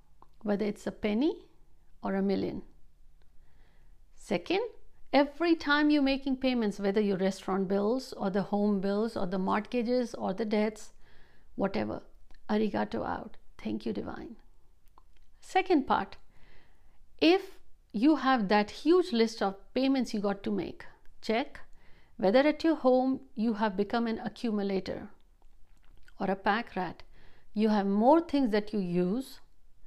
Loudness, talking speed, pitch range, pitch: -30 LUFS, 135 wpm, 200-265 Hz, 220 Hz